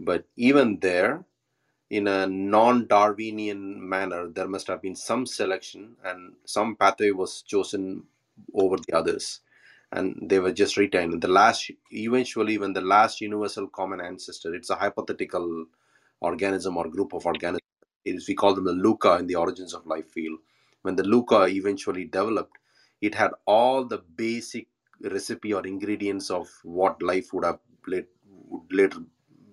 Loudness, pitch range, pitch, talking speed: -25 LUFS, 95-105 Hz, 95 Hz, 150 wpm